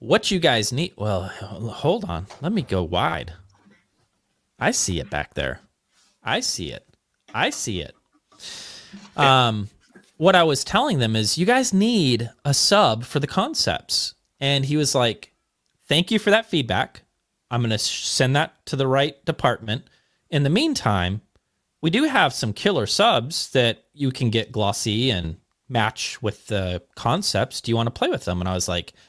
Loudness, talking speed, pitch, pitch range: -22 LUFS, 175 wpm, 120 Hz, 105-150 Hz